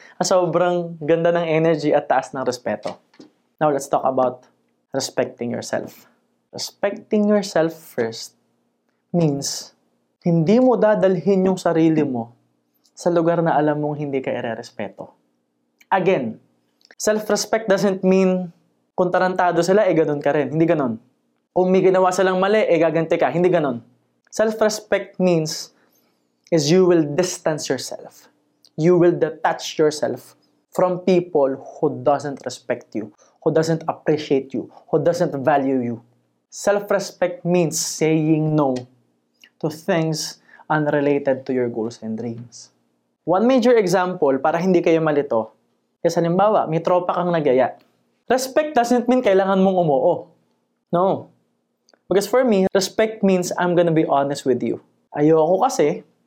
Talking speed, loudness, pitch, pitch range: 135 wpm, -19 LUFS, 165 Hz, 140-185 Hz